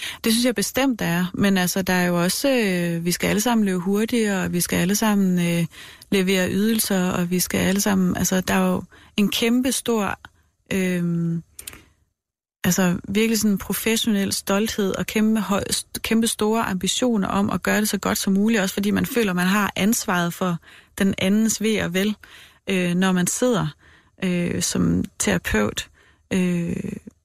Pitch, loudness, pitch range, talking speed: 195 Hz, -21 LUFS, 180-215 Hz, 175 wpm